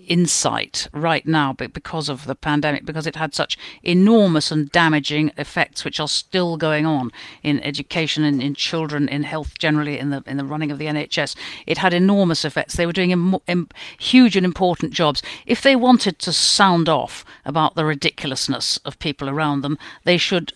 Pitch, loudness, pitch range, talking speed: 155 Hz, -19 LUFS, 145-175 Hz, 190 wpm